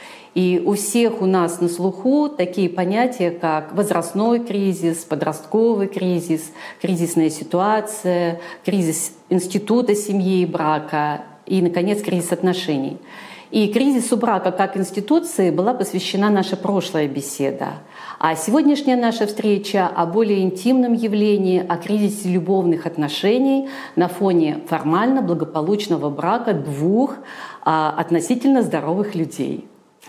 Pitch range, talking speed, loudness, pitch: 170-215 Hz, 110 wpm, -19 LUFS, 185 Hz